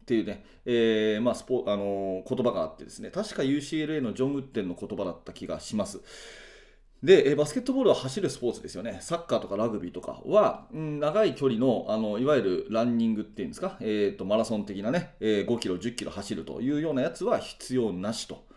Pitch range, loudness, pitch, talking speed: 105-150 Hz, -28 LUFS, 120 Hz, 420 characters per minute